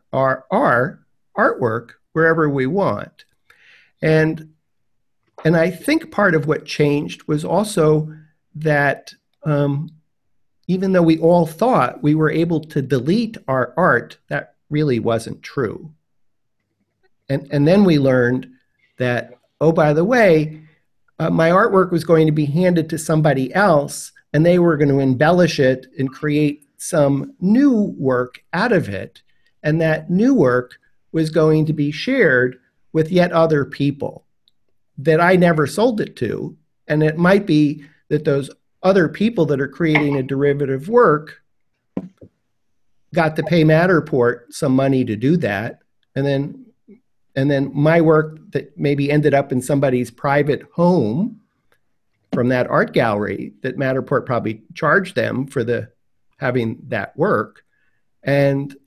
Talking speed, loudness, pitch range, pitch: 145 wpm, -18 LUFS, 135-165 Hz, 150 Hz